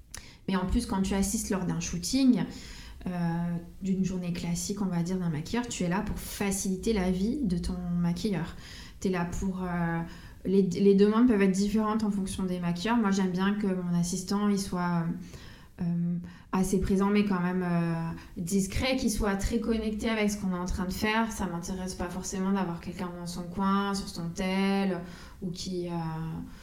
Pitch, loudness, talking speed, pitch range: 190 Hz, -29 LUFS, 195 wpm, 175-200 Hz